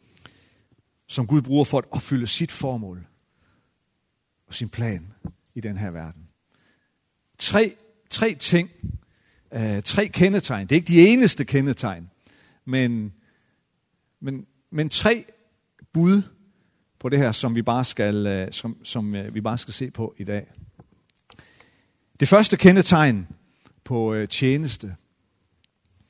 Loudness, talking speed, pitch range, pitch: -21 LUFS, 120 wpm, 100-150 Hz, 120 Hz